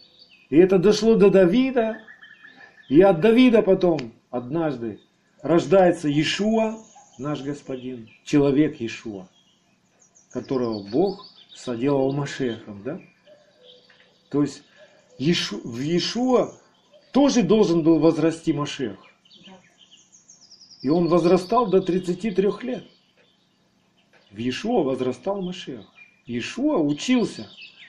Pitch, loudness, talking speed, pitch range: 175 Hz, -21 LUFS, 90 wpm, 145-215 Hz